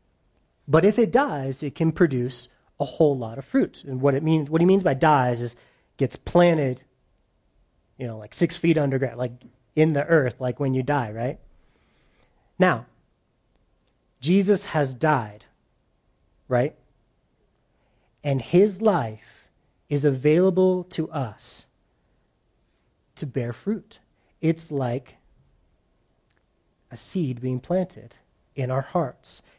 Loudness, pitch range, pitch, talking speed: -23 LUFS, 125-165 Hz, 135 Hz, 130 wpm